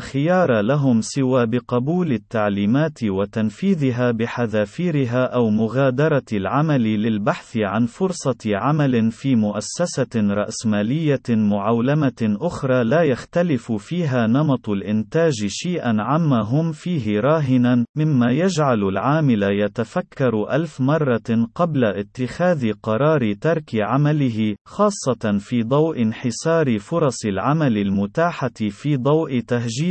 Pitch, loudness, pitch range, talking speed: 125 Hz, -20 LUFS, 110-150 Hz, 100 wpm